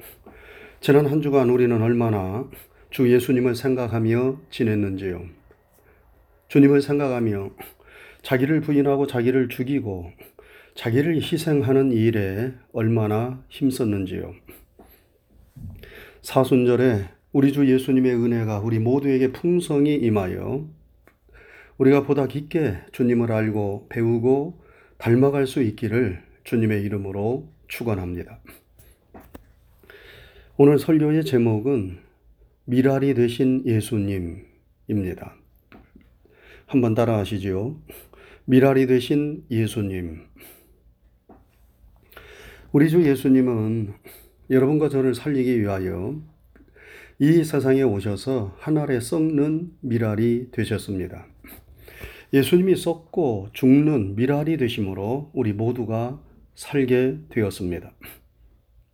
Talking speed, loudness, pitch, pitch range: 225 characters per minute, -22 LUFS, 125 Hz, 105-140 Hz